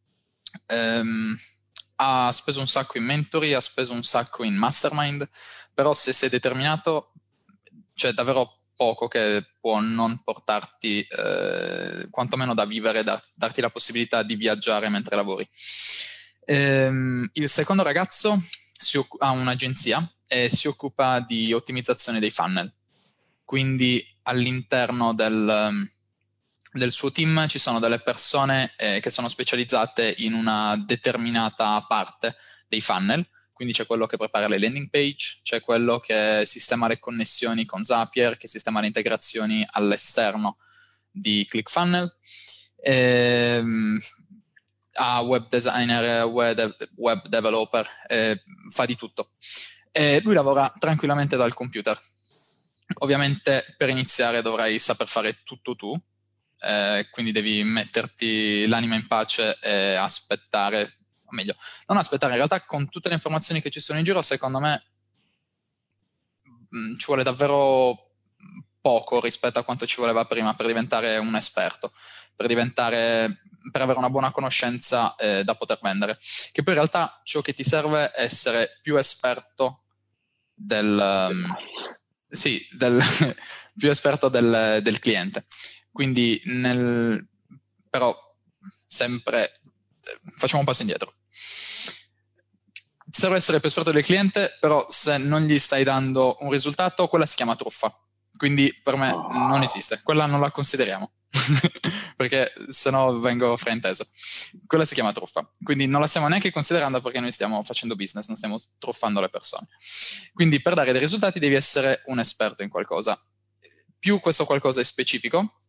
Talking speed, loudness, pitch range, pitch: 135 wpm, -22 LUFS, 115-145 Hz, 125 Hz